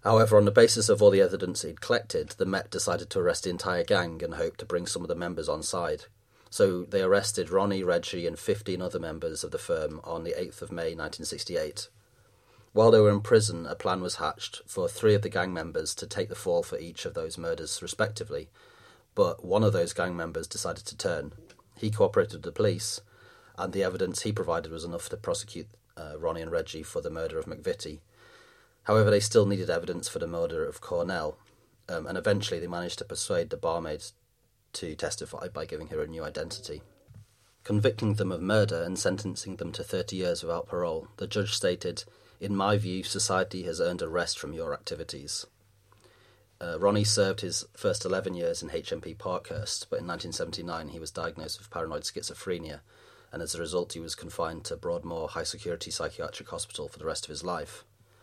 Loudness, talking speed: -29 LUFS, 200 wpm